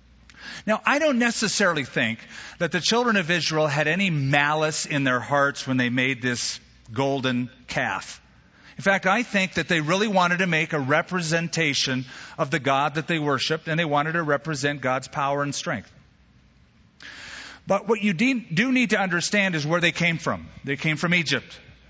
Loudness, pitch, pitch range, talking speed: -23 LUFS, 160 Hz, 140-185 Hz, 180 wpm